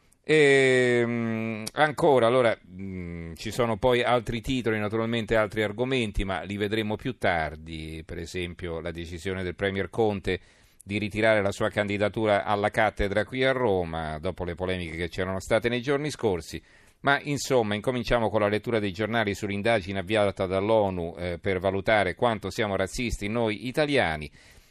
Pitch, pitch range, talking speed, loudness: 105 Hz, 95-115 Hz, 155 wpm, -26 LUFS